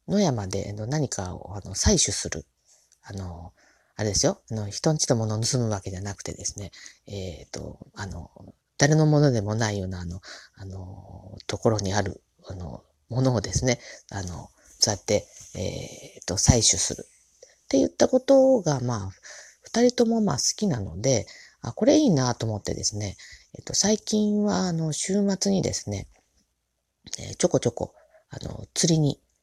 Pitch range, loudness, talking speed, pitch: 95-155 Hz, -24 LUFS, 300 characters per minute, 110 Hz